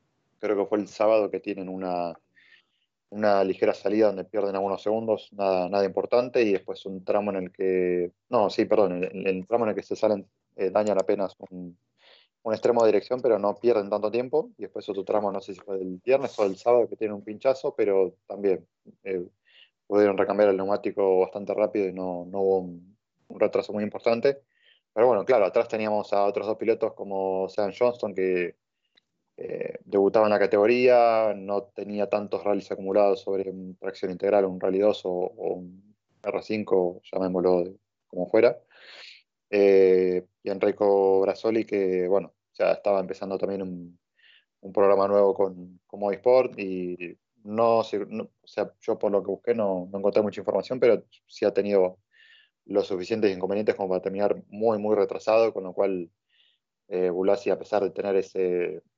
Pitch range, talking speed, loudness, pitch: 95-105 Hz, 185 wpm, -25 LUFS, 100 Hz